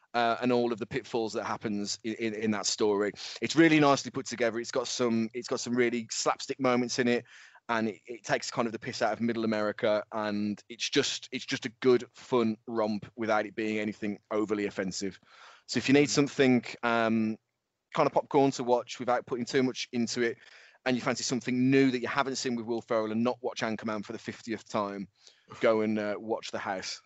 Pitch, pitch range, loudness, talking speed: 115 Hz, 110-125 Hz, -30 LUFS, 220 wpm